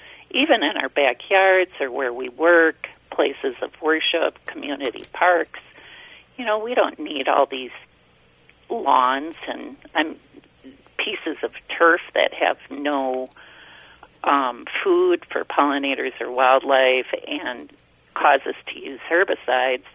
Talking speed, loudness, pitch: 125 wpm, -21 LUFS, 160 Hz